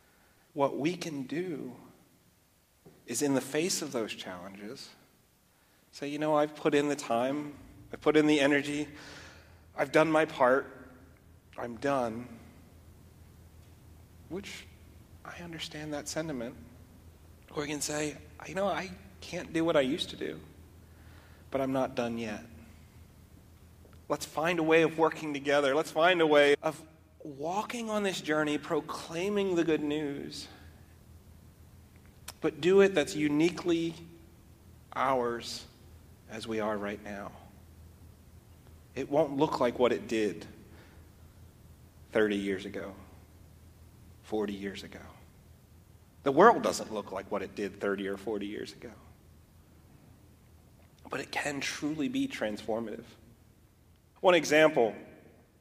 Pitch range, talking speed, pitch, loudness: 90-150 Hz, 130 wpm, 110 Hz, -30 LUFS